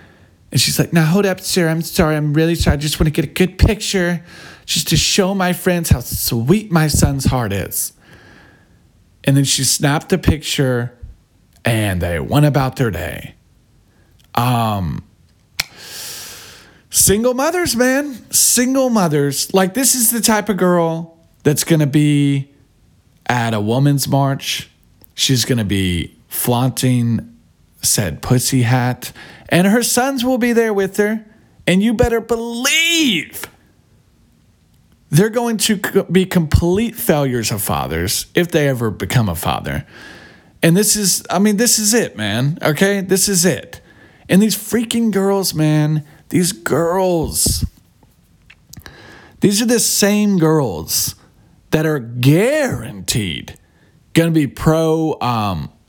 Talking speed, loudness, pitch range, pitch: 140 wpm, -16 LUFS, 120-195 Hz, 155 Hz